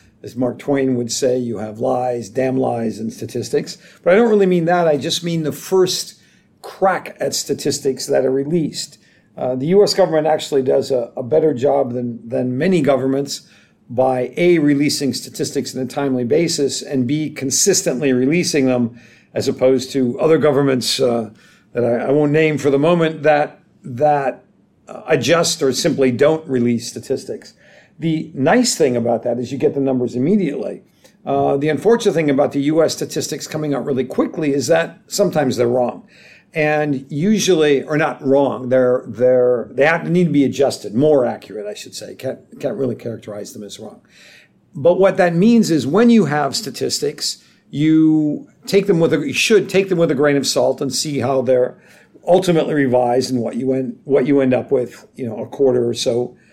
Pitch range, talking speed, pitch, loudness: 125-160 Hz, 185 wpm, 140 Hz, -17 LUFS